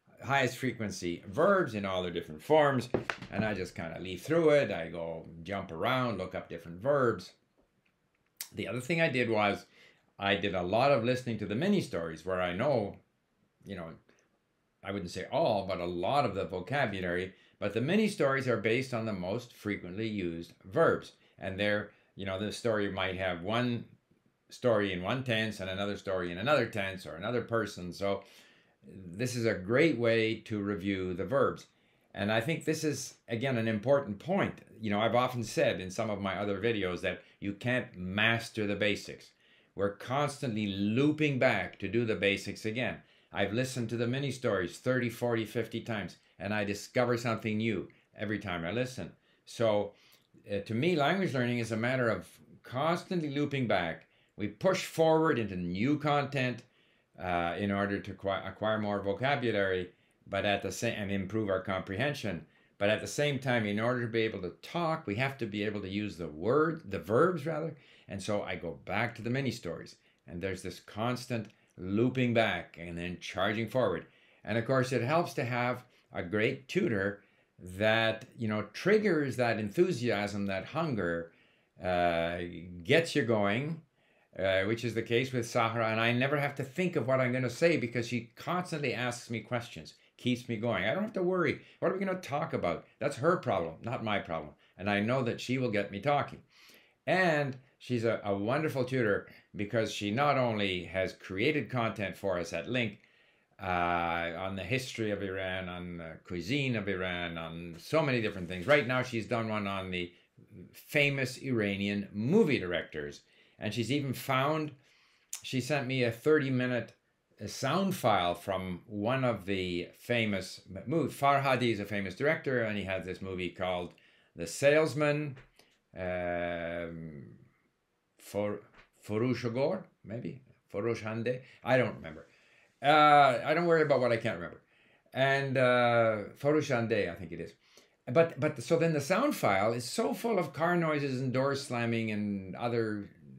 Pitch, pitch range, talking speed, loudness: 115 Hz, 95-130 Hz, 175 wpm, -32 LUFS